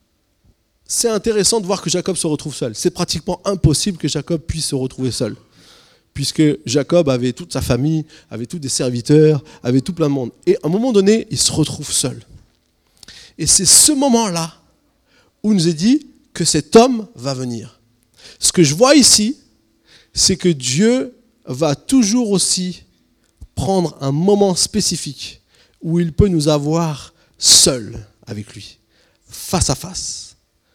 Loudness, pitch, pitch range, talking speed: -15 LUFS, 160 Hz, 130-195 Hz, 160 wpm